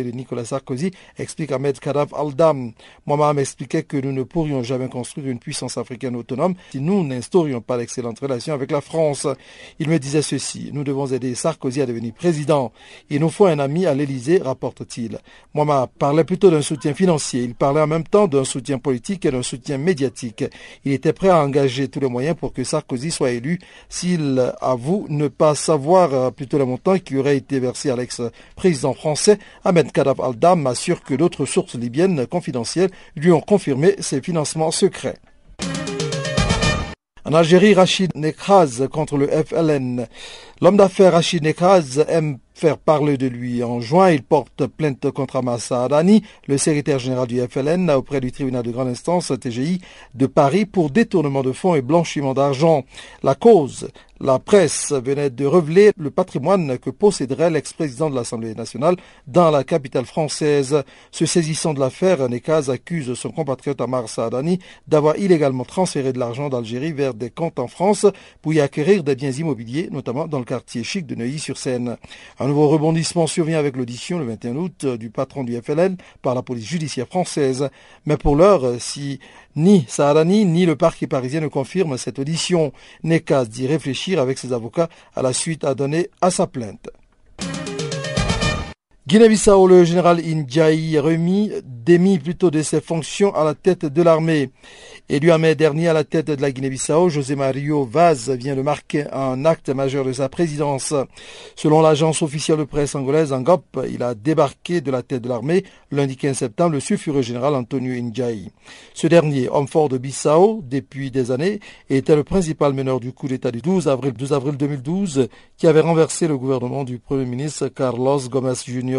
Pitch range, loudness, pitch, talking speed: 130-165 Hz, -19 LUFS, 145 Hz, 175 wpm